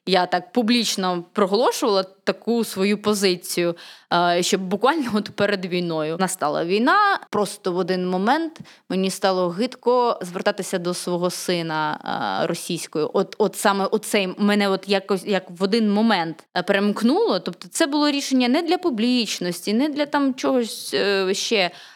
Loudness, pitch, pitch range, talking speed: -21 LUFS, 200 Hz, 185-230 Hz, 140 wpm